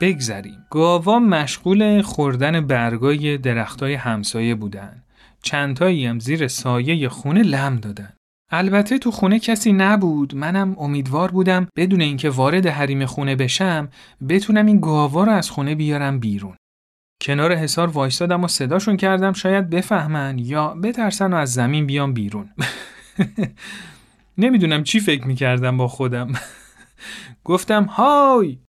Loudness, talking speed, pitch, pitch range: -19 LUFS, 125 wpm, 150 Hz, 130-190 Hz